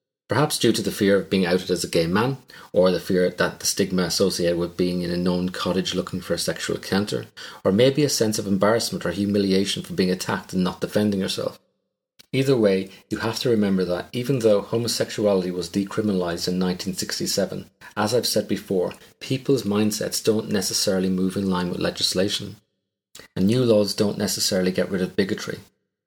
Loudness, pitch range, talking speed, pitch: -23 LUFS, 90-110 Hz, 185 wpm, 100 Hz